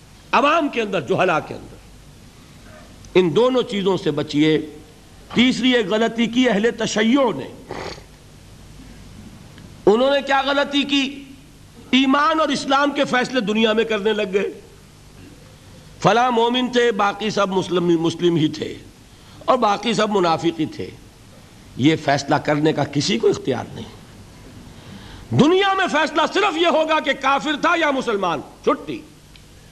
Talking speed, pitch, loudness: 135 wpm, 215 Hz, -19 LUFS